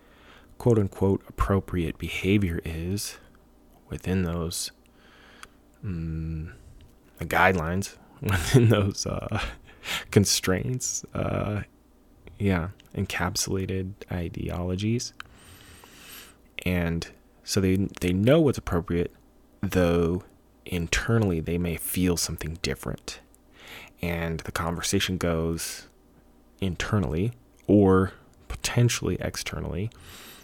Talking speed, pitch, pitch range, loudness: 80 wpm, 90 Hz, 85-100 Hz, -27 LUFS